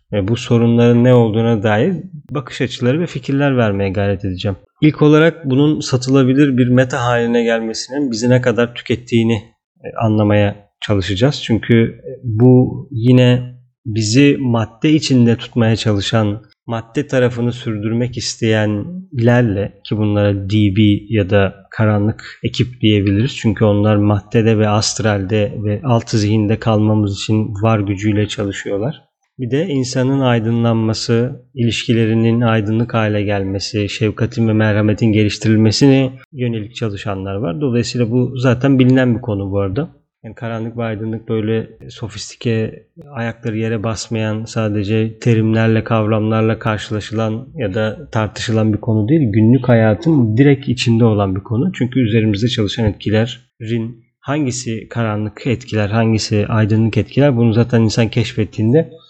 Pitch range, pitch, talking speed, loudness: 110-125 Hz, 115 Hz, 125 wpm, -15 LUFS